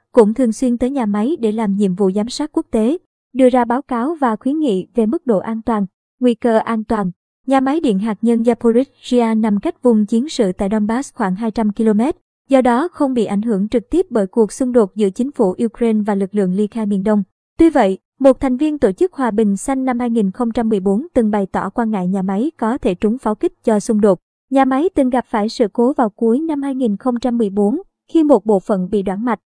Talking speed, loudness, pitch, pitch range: 230 wpm, -17 LUFS, 230 Hz, 210-260 Hz